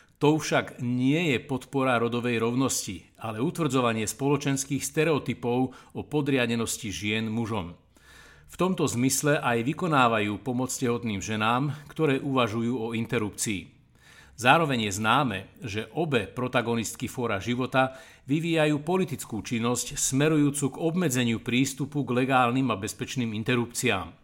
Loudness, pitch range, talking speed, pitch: -26 LUFS, 115-140 Hz, 115 wpm, 125 Hz